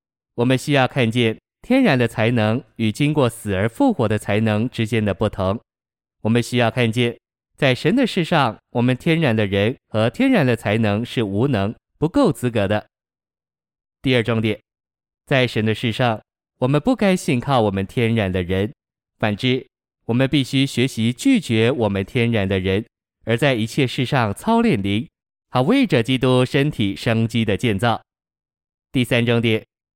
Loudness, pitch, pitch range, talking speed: -19 LUFS, 120 Hz, 110-135 Hz, 240 characters per minute